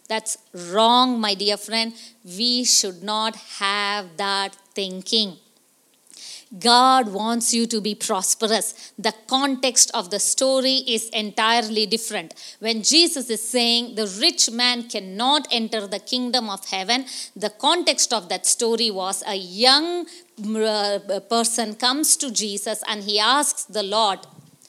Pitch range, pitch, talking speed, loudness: 205-245 Hz, 225 Hz, 135 wpm, -20 LUFS